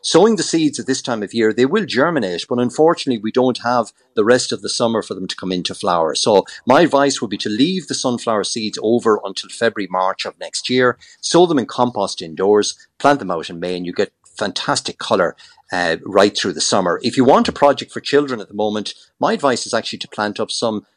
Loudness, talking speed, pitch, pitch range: -17 LUFS, 235 wpm, 120 Hz, 105-130 Hz